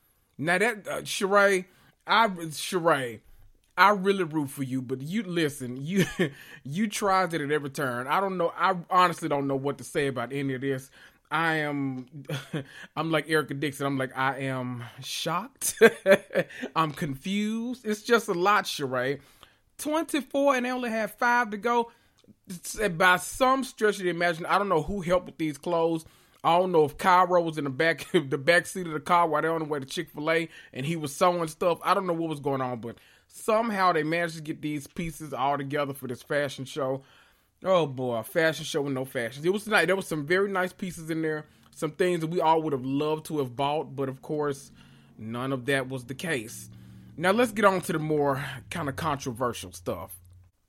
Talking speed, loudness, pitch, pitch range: 210 wpm, -27 LUFS, 155 Hz, 135-185 Hz